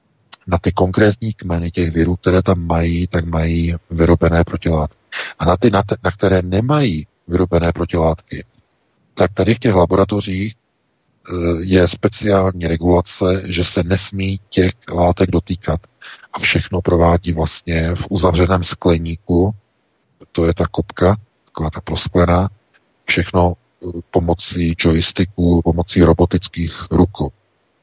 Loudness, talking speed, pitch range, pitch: -17 LUFS, 120 wpm, 85-95 Hz, 90 Hz